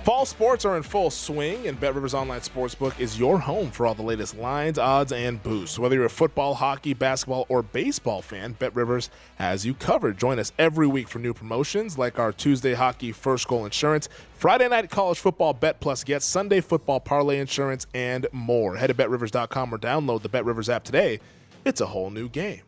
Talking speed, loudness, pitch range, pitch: 205 wpm, -25 LUFS, 120-150 Hz, 130 Hz